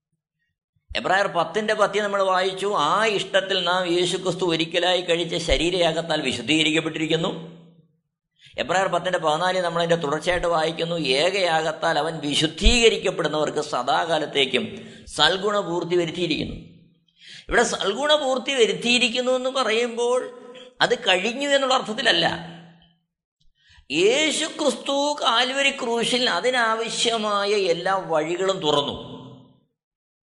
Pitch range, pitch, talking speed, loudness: 165-230 Hz, 180 Hz, 90 wpm, -21 LUFS